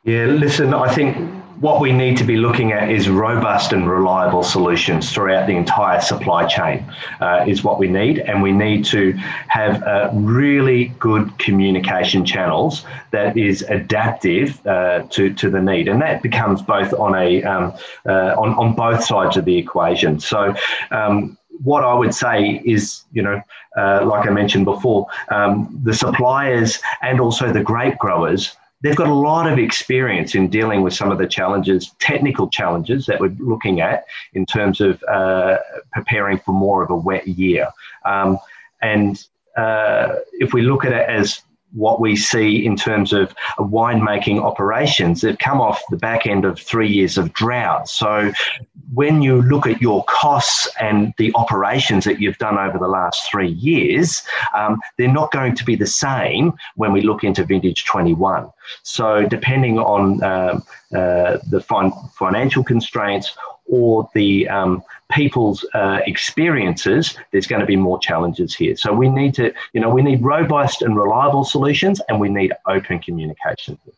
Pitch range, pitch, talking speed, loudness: 95-125 Hz, 105 Hz, 170 wpm, -17 LUFS